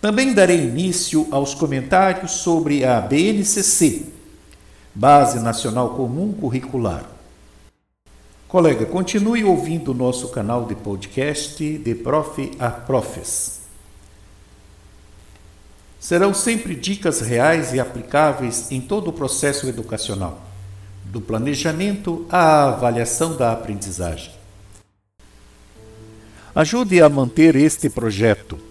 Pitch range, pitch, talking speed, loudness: 100-160 Hz, 125 Hz, 95 wpm, -18 LUFS